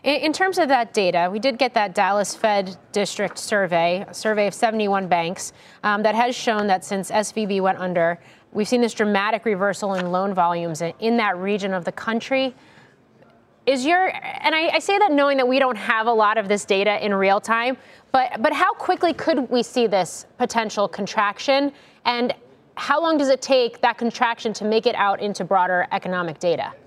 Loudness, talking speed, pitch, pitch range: -21 LUFS, 195 wpm, 215 Hz, 195-260 Hz